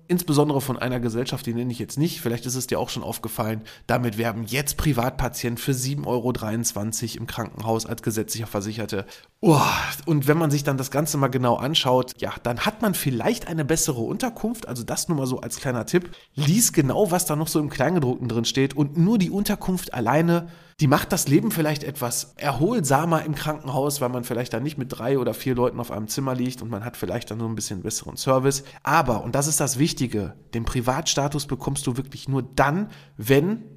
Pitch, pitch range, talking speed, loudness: 135 Hz, 120-155 Hz, 210 wpm, -24 LUFS